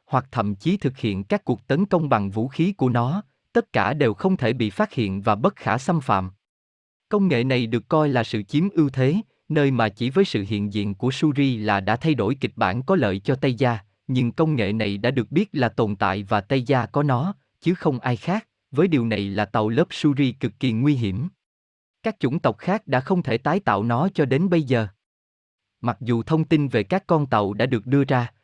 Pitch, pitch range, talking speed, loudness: 125 Hz, 110-155 Hz, 240 wpm, -22 LUFS